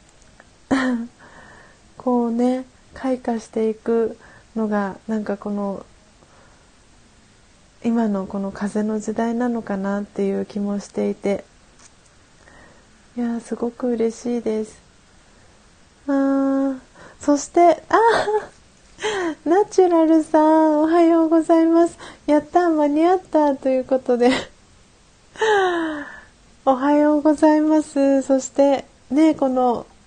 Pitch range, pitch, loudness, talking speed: 225-310 Hz, 265 Hz, -20 LUFS, 200 characters per minute